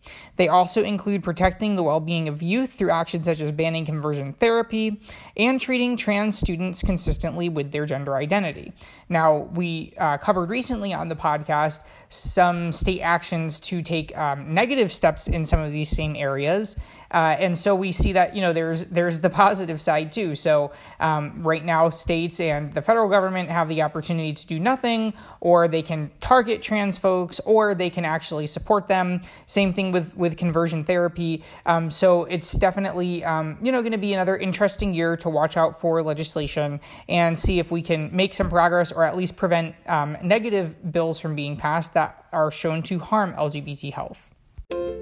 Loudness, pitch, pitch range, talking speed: -22 LUFS, 170 Hz, 160-190 Hz, 180 wpm